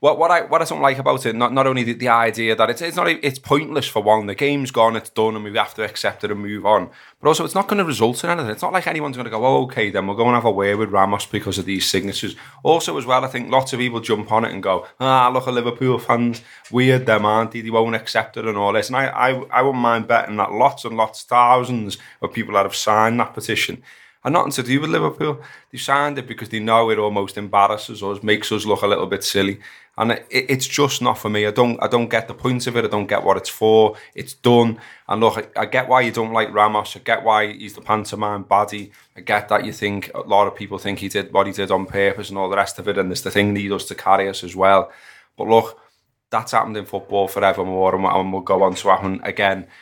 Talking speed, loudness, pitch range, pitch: 275 wpm, -19 LUFS, 100-125 Hz, 110 Hz